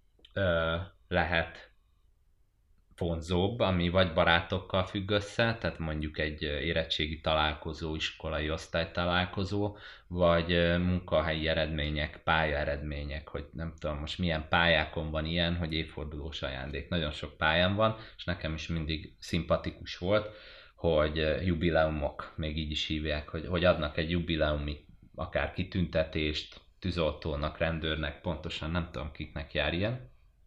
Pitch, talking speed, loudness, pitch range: 80 Hz, 120 wpm, -31 LUFS, 75-90 Hz